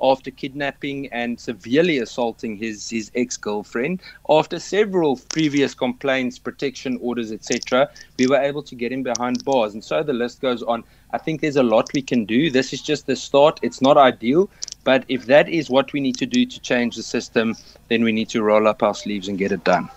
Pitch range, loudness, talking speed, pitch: 115-140 Hz, -21 LUFS, 210 wpm, 125 Hz